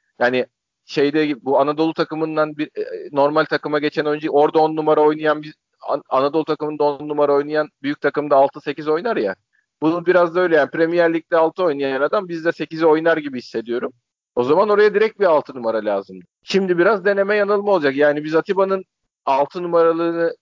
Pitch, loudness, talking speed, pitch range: 155 Hz, -19 LUFS, 175 wpm, 145-170 Hz